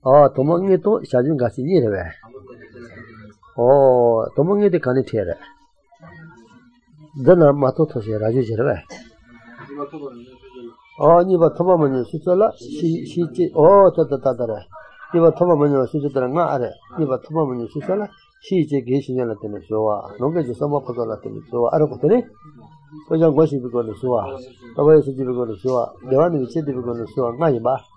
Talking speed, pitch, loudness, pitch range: 195 wpm, 140 Hz, -18 LUFS, 125-165 Hz